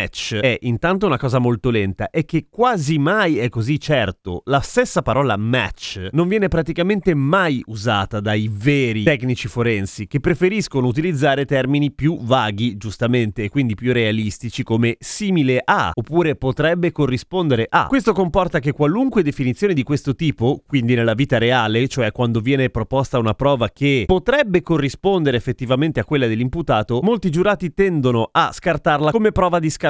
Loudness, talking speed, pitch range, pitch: -18 LUFS, 155 wpm, 120-165 Hz, 135 Hz